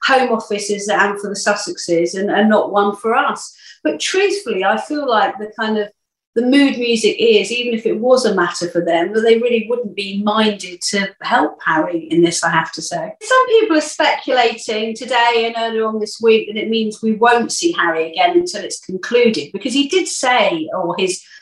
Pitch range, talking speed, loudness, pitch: 200-265 Hz, 205 wpm, -16 LUFS, 225 Hz